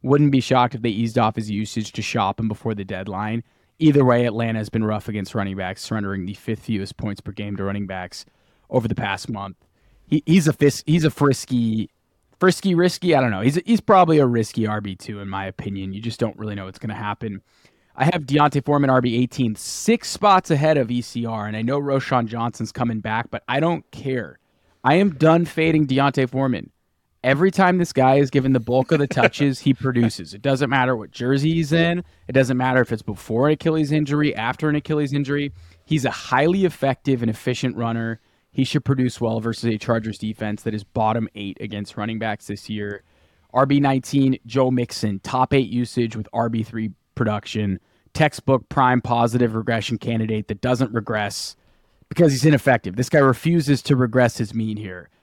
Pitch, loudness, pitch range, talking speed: 120 Hz, -21 LUFS, 110-140 Hz, 195 wpm